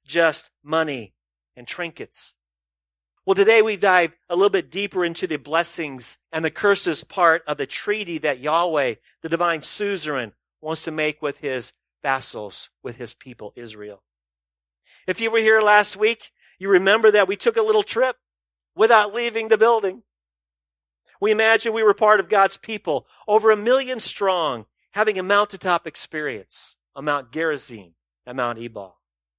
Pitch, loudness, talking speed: 165 Hz, -20 LUFS, 155 wpm